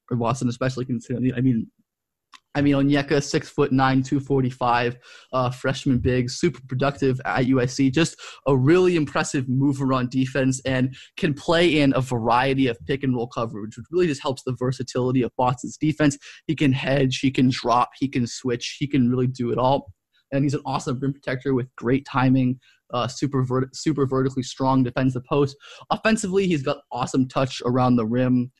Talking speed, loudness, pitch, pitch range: 185 wpm, -23 LUFS, 130 Hz, 125-140 Hz